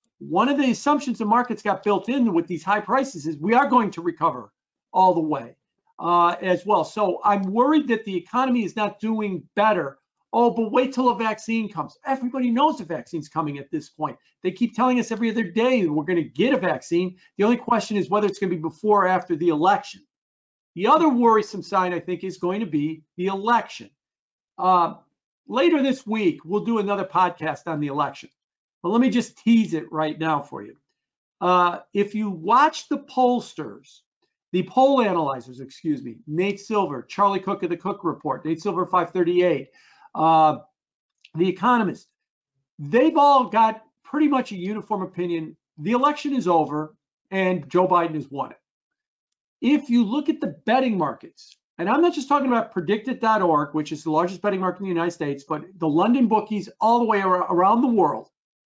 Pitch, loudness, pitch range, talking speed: 200 Hz, -22 LUFS, 170-240 Hz, 190 wpm